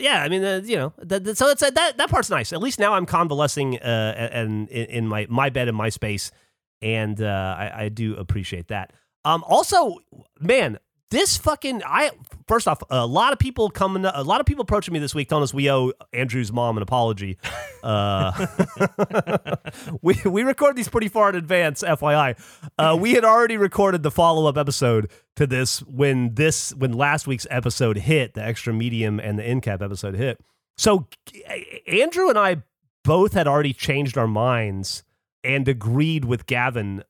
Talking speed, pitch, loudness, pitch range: 190 wpm, 140 Hz, -21 LUFS, 115-185 Hz